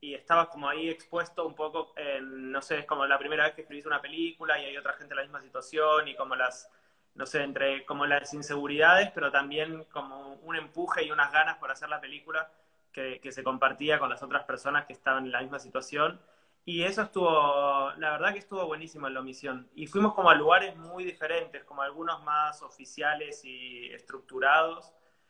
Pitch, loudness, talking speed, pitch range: 150 Hz, -29 LUFS, 205 wpm, 140-165 Hz